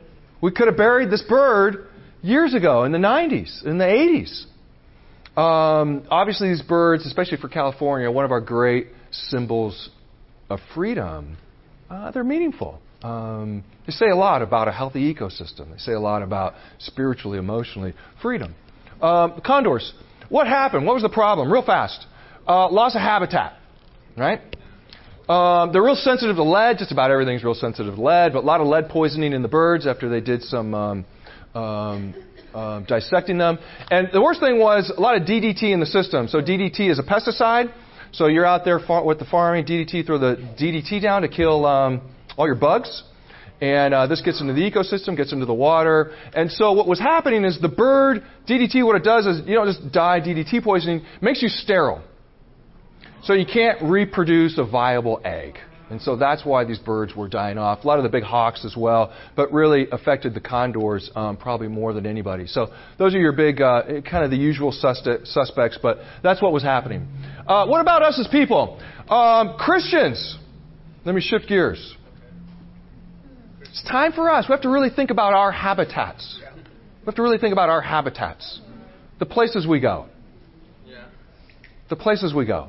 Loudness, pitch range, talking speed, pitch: -19 LUFS, 120-200 Hz, 185 wpm, 160 Hz